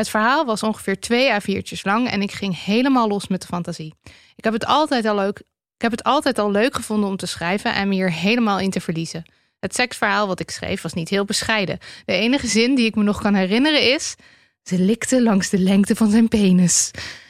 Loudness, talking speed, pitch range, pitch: -19 LUFS, 230 wpm, 190-230 Hz, 205 Hz